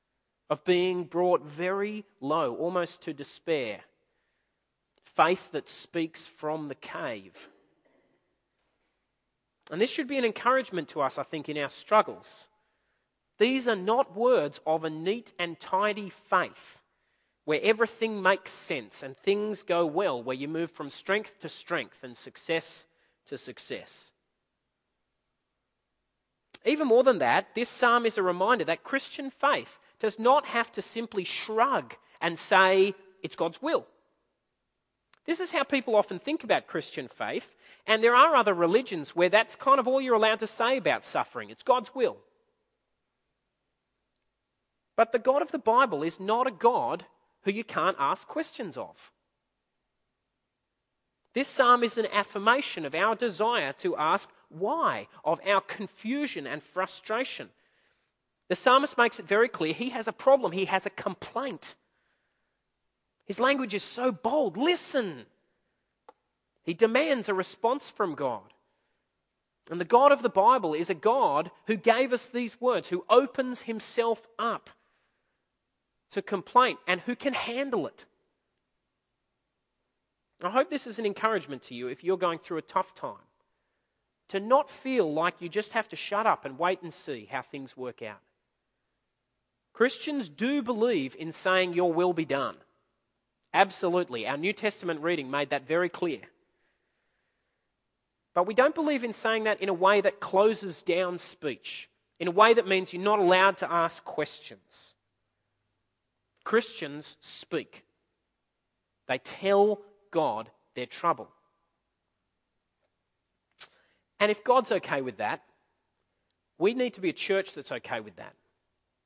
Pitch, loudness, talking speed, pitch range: 200 Hz, -27 LUFS, 145 wpm, 170-240 Hz